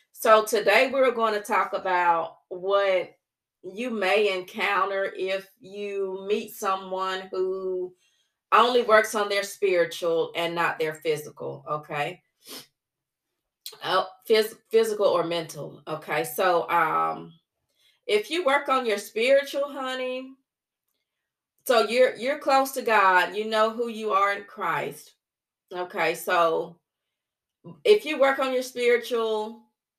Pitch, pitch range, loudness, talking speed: 200 Hz, 180-235 Hz, -24 LUFS, 125 wpm